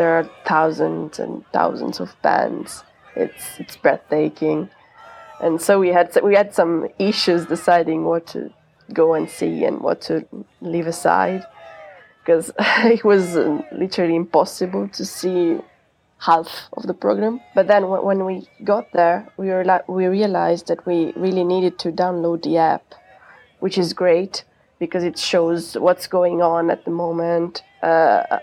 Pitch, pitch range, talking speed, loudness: 175 Hz, 165-190 Hz, 150 wpm, -19 LUFS